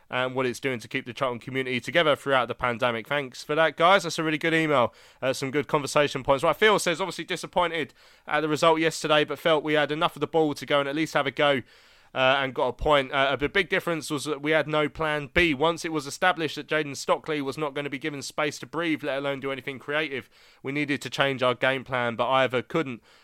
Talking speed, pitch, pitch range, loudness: 255 wpm, 150 Hz, 135-160 Hz, -25 LUFS